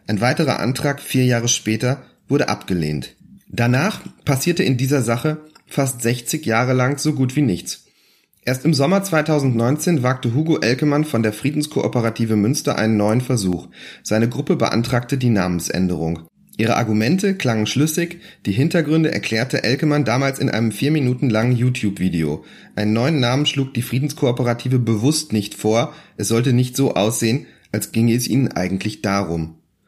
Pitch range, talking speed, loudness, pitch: 110-145 Hz, 150 wpm, -19 LUFS, 125 Hz